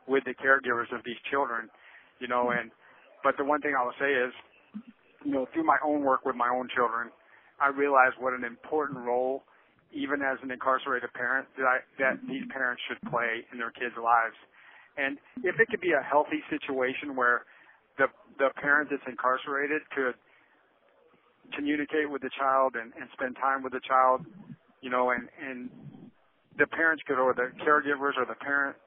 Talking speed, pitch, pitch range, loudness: 180 wpm, 135 Hz, 125-145 Hz, -28 LUFS